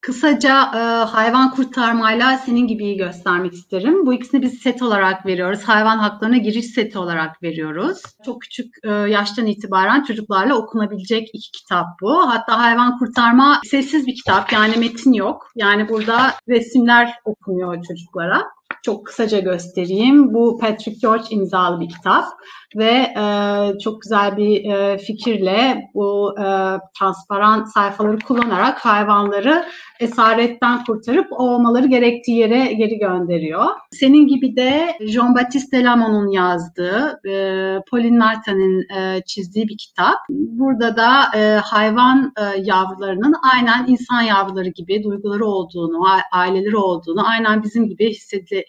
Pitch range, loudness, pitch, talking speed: 195-245 Hz, -16 LUFS, 220 Hz, 125 wpm